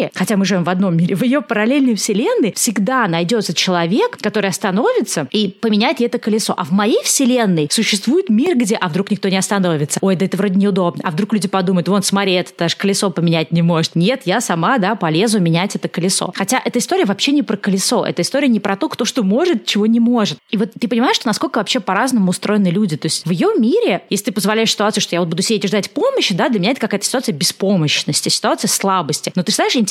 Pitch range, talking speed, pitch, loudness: 185-230 Hz, 230 wpm, 205 Hz, -16 LUFS